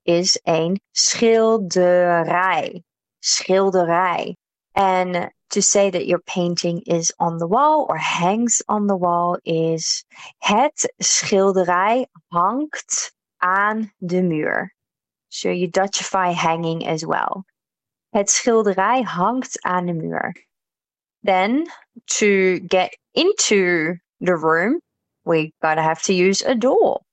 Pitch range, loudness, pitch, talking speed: 175-220 Hz, -19 LUFS, 185 Hz, 115 wpm